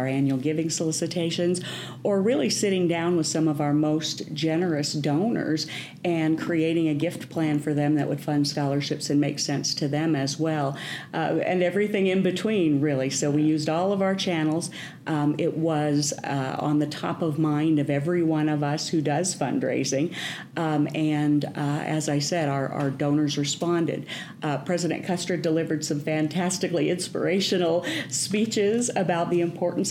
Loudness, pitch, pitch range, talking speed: -25 LUFS, 155 Hz, 150-175 Hz, 170 wpm